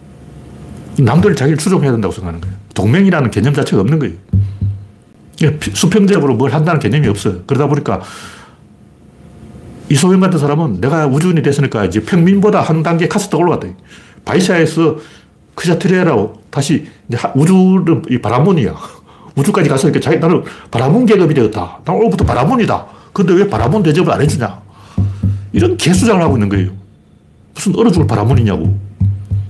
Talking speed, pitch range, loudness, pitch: 370 characters per minute, 105-175 Hz, -13 LUFS, 140 Hz